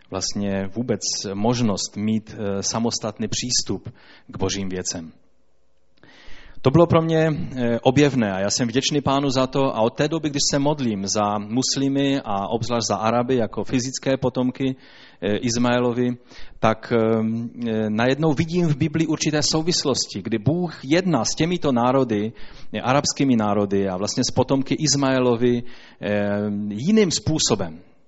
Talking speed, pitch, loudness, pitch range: 130 wpm, 125 Hz, -21 LUFS, 110-140 Hz